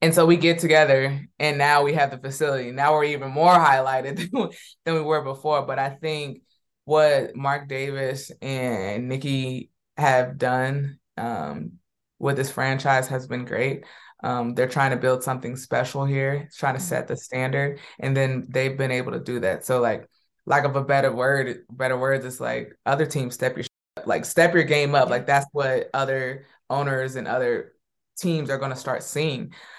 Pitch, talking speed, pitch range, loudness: 135 Hz, 185 wpm, 130-145 Hz, -23 LUFS